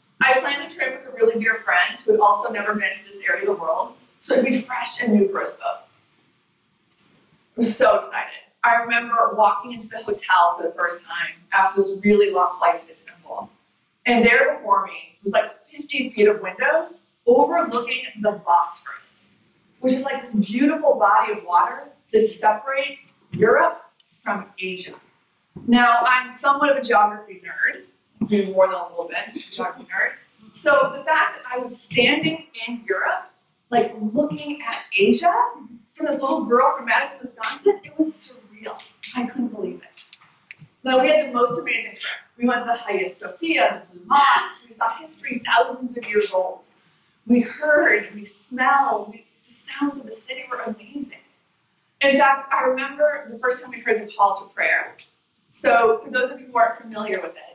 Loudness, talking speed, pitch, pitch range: -21 LUFS, 185 wpm, 235 Hz, 205-265 Hz